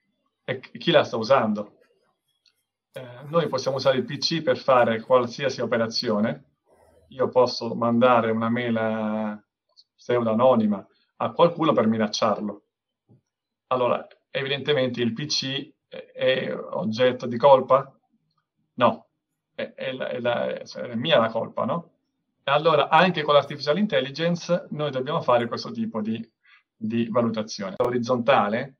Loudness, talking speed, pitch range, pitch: -23 LUFS, 125 wpm, 115-150 Hz, 125 Hz